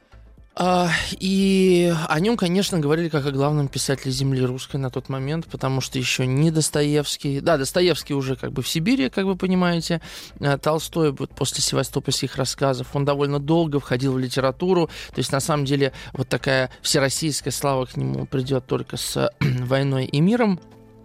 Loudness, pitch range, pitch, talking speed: -22 LUFS, 135-165 Hz, 145 Hz, 165 wpm